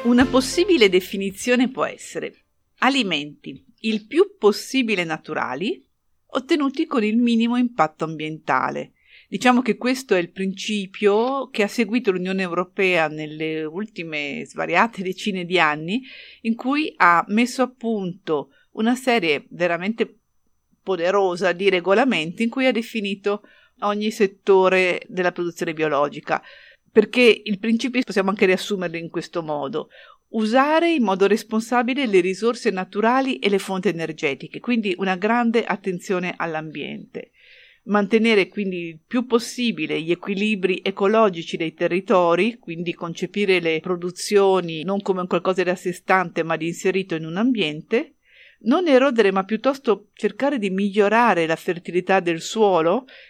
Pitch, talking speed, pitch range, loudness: 200 Hz, 130 wpm, 180-235 Hz, -21 LUFS